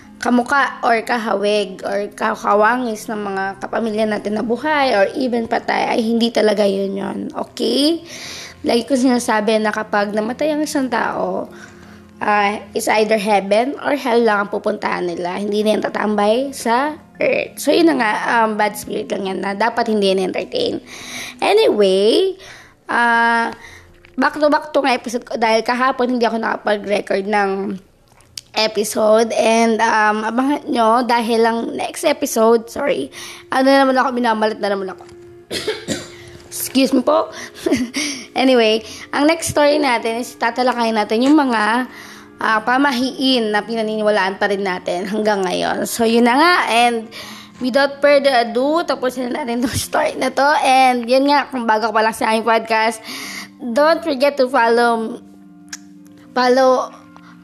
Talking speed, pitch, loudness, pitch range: 150 wpm, 230 Hz, -17 LUFS, 210-260 Hz